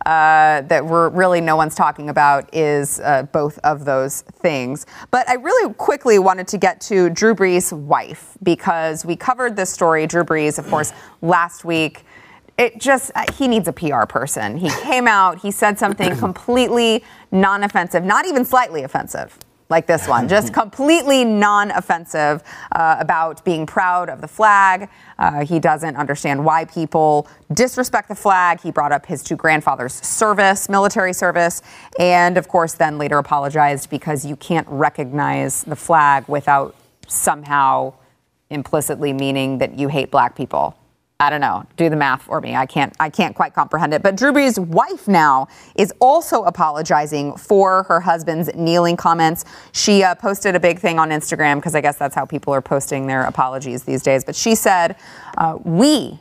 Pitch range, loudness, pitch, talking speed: 145-195 Hz, -17 LUFS, 165 Hz, 175 wpm